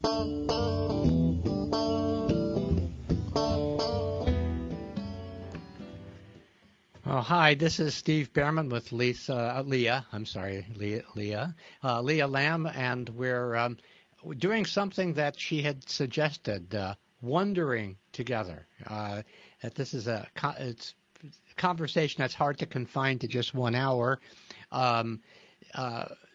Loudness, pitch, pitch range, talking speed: -30 LUFS, 125 Hz, 100-145 Hz, 110 wpm